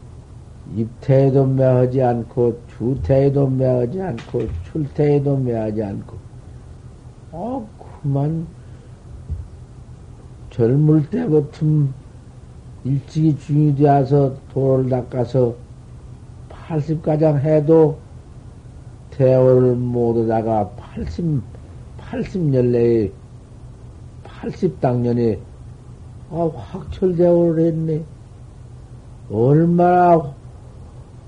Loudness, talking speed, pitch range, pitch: -18 LUFS, 145 characters per minute, 120-150 Hz, 125 Hz